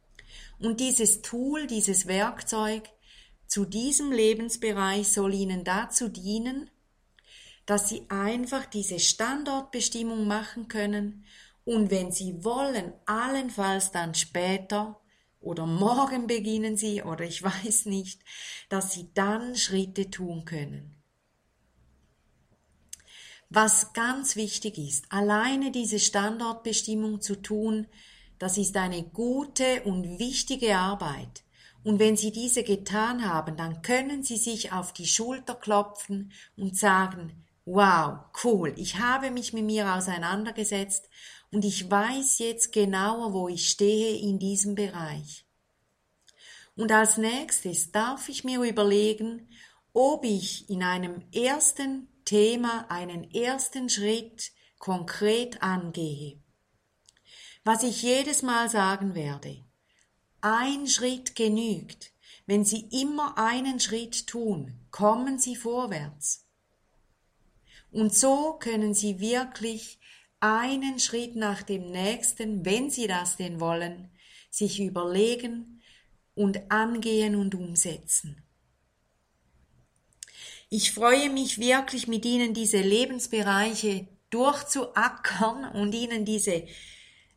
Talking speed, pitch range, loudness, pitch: 110 wpm, 190-235 Hz, -27 LUFS, 210 Hz